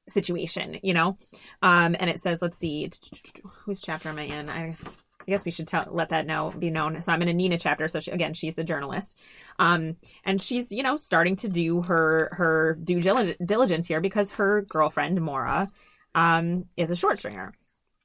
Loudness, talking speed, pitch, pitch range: -26 LUFS, 195 wpm, 170 Hz, 160-190 Hz